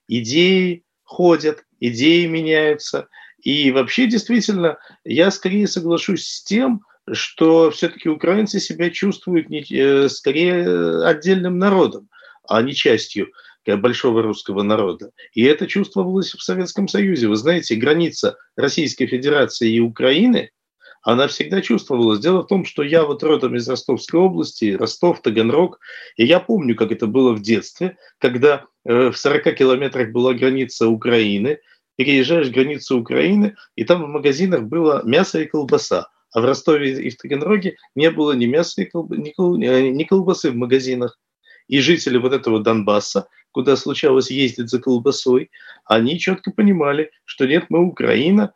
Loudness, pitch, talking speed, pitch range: -17 LUFS, 160 Hz, 140 wpm, 130-185 Hz